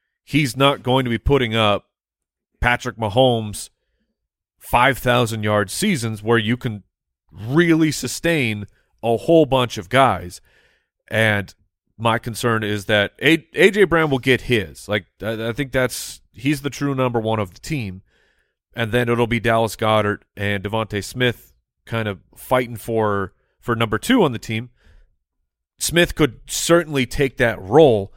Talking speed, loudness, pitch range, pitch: 150 wpm, -19 LUFS, 105-130 Hz, 115 Hz